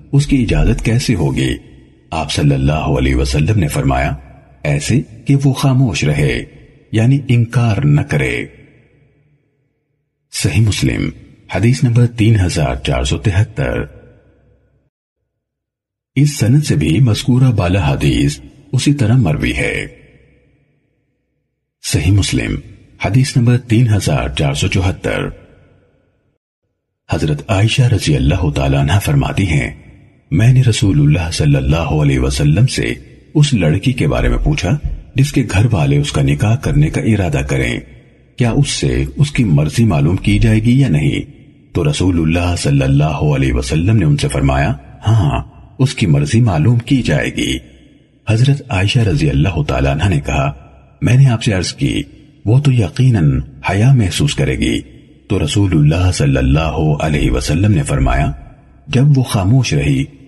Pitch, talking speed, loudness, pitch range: 120 Hz, 150 wpm, -14 LUFS, 95-140 Hz